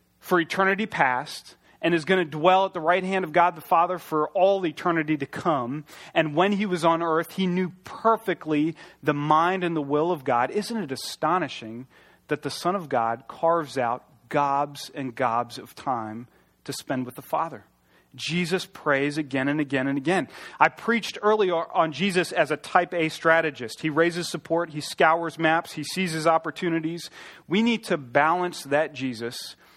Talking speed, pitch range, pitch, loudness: 180 wpm, 145-180 Hz, 160 Hz, -25 LUFS